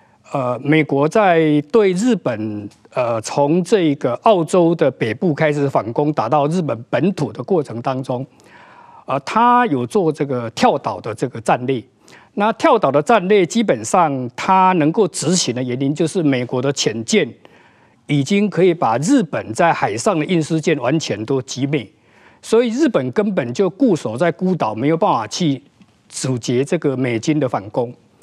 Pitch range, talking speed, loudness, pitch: 130-185 Hz, 240 characters per minute, -17 LUFS, 150 Hz